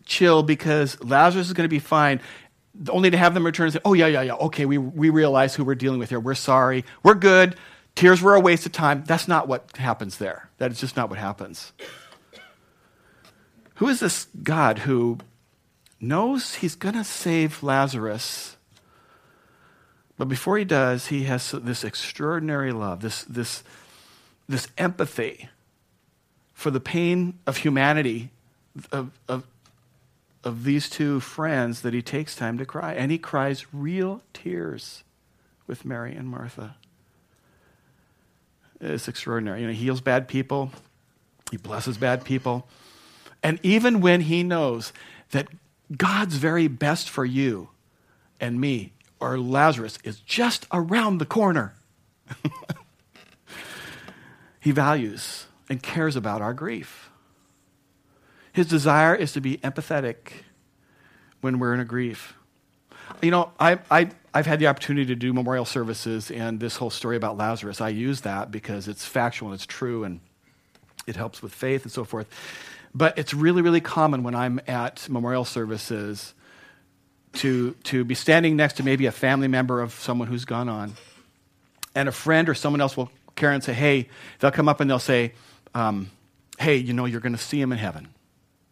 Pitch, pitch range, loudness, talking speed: 135 Hz, 120-155 Hz, -23 LUFS, 160 wpm